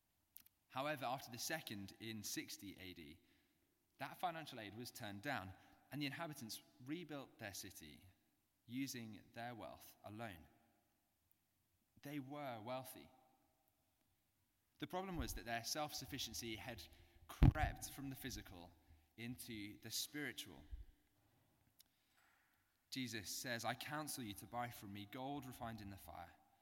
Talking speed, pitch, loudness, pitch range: 125 wpm, 115 Hz, -47 LUFS, 100-130 Hz